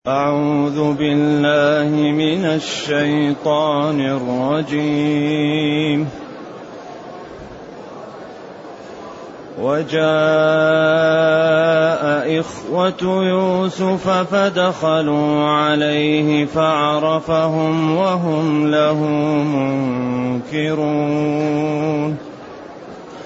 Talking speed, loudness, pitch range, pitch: 35 wpm, -17 LUFS, 150-160 Hz, 150 Hz